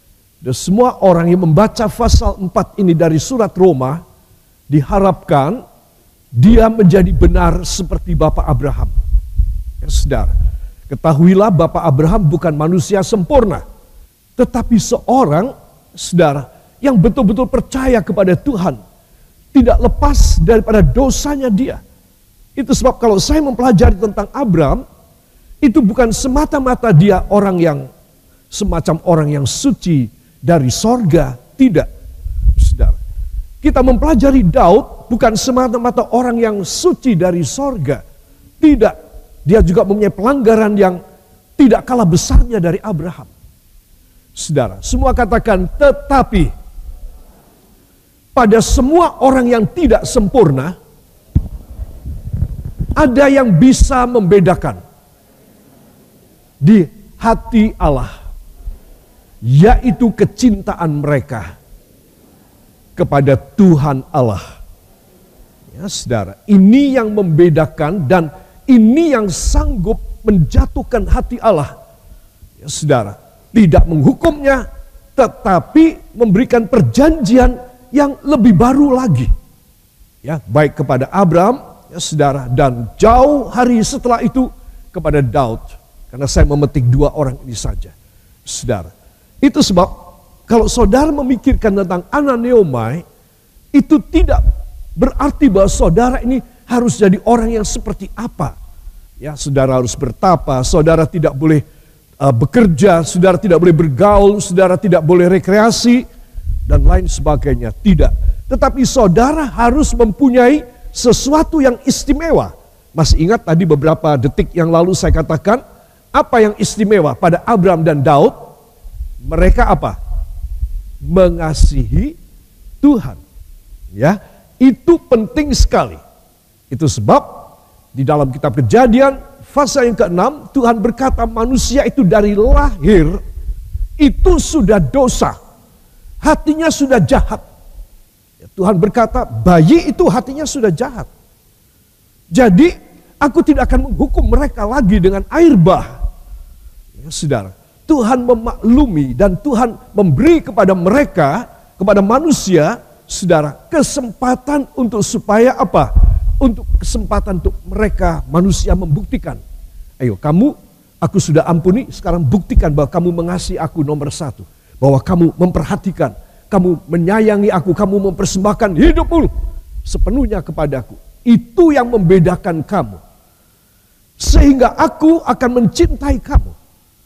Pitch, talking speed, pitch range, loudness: 195 Hz, 105 wpm, 150-245 Hz, -12 LUFS